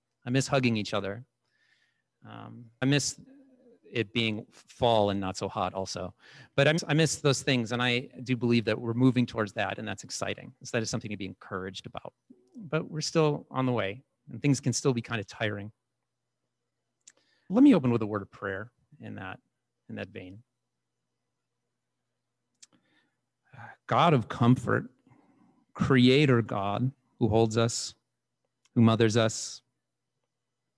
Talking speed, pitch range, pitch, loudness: 160 wpm, 110-135 Hz, 120 Hz, -28 LUFS